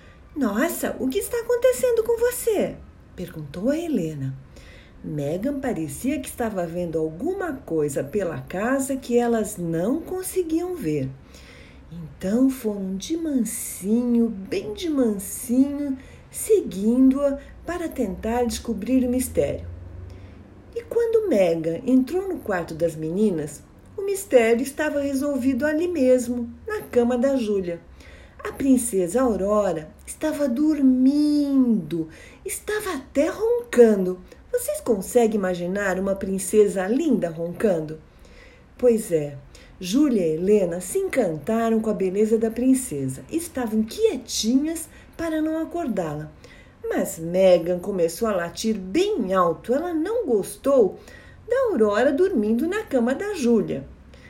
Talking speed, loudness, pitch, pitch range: 115 wpm, -23 LUFS, 240 Hz, 185-295 Hz